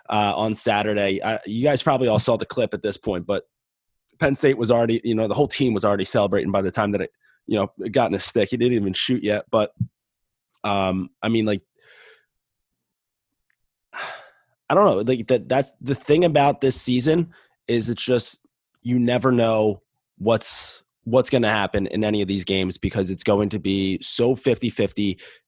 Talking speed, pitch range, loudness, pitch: 195 wpm, 100-125 Hz, -21 LUFS, 110 Hz